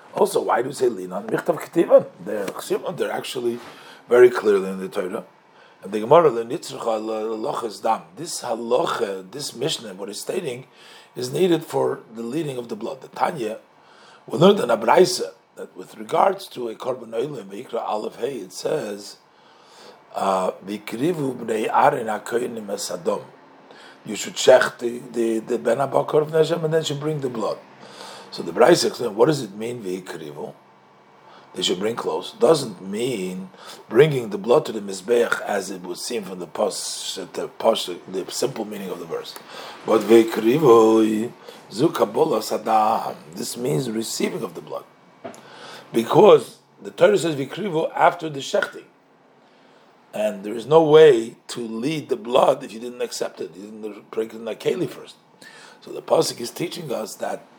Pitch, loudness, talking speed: 125 Hz, -21 LUFS, 145 wpm